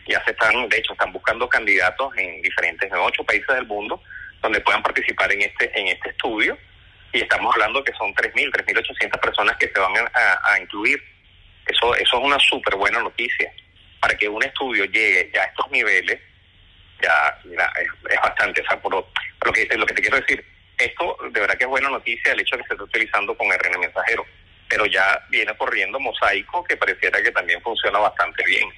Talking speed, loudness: 200 wpm, -19 LUFS